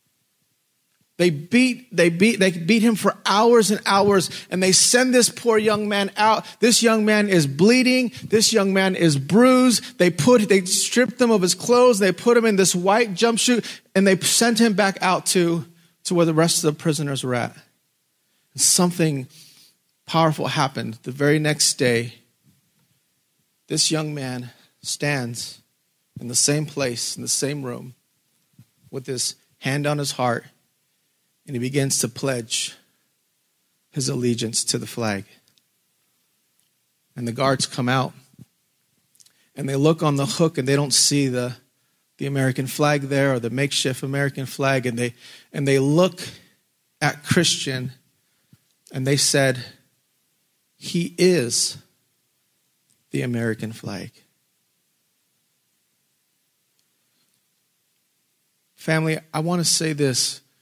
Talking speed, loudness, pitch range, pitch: 140 wpm, -20 LUFS, 135-190 Hz, 150 Hz